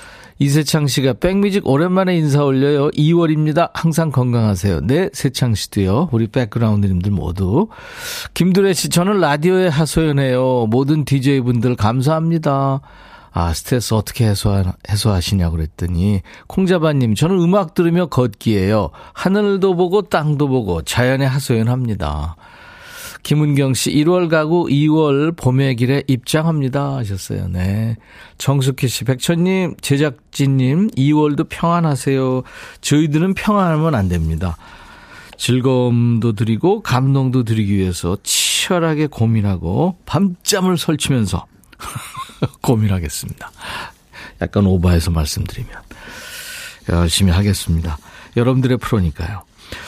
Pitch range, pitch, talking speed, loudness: 105-165 Hz, 135 Hz, 295 characters per minute, -16 LUFS